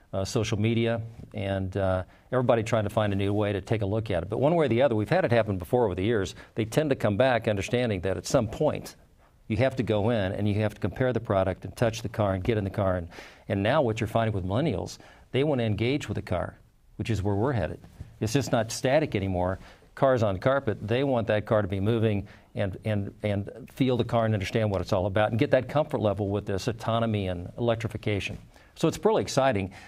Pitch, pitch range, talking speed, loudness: 110 Hz, 100-115 Hz, 250 wpm, -27 LUFS